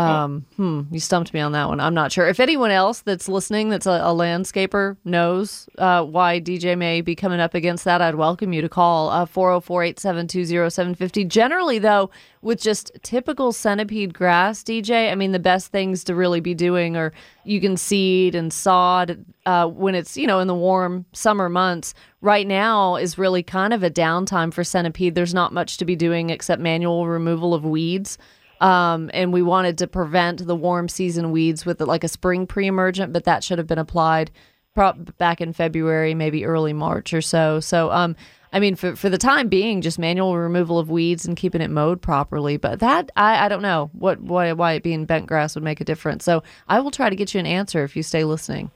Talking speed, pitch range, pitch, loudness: 210 wpm, 165-190 Hz, 175 Hz, -20 LUFS